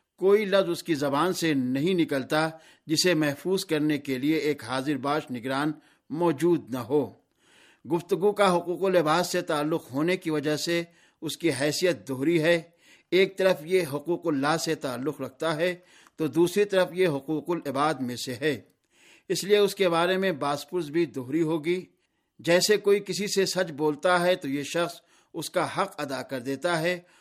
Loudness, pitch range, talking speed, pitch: -26 LUFS, 150-180 Hz, 175 wpm, 165 Hz